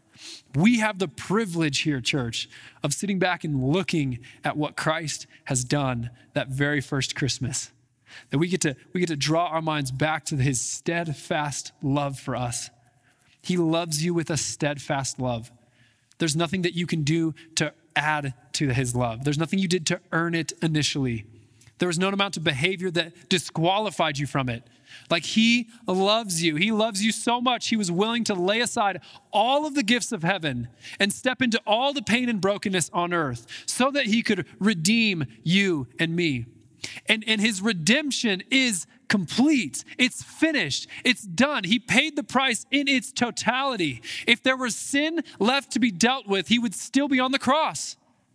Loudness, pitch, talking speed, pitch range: -24 LUFS, 170 Hz, 180 wpm, 145-220 Hz